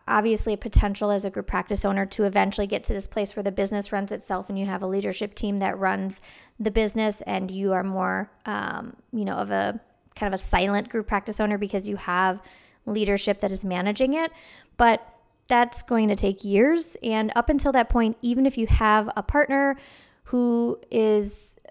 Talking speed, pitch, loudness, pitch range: 200 wpm, 210 Hz, -25 LUFS, 200-230 Hz